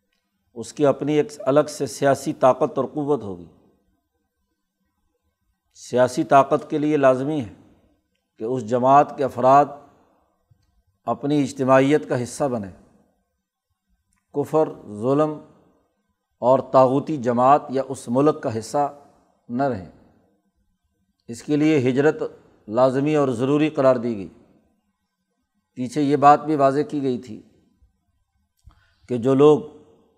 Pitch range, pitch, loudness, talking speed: 105-145 Hz, 130 Hz, -20 LUFS, 120 wpm